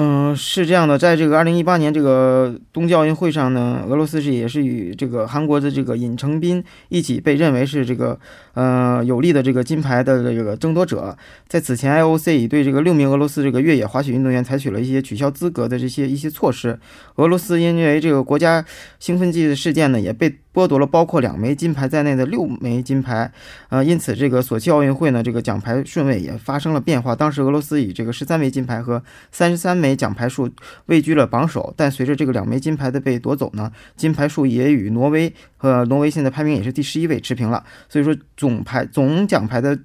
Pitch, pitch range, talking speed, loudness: 140 Hz, 125-155 Hz, 345 characters per minute, -18 LUFS